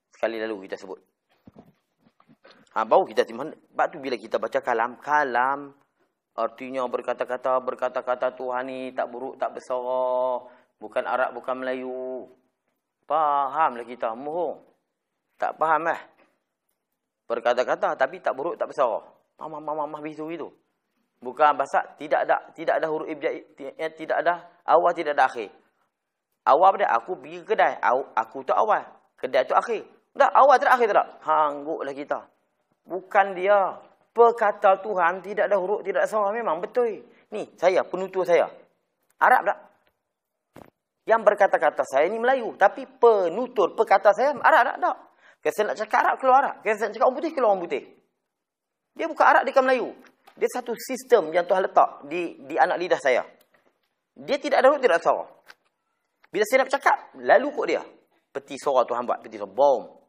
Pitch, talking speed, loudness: 170 Hz, 165 wpm, -23 LUFS